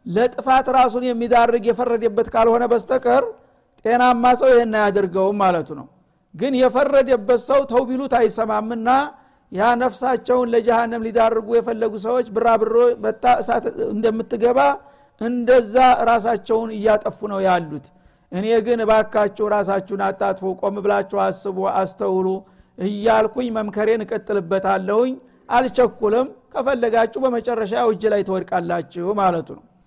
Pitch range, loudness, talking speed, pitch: 205-245 Hz, -19 LUFS, 100 wpm, 230 Hz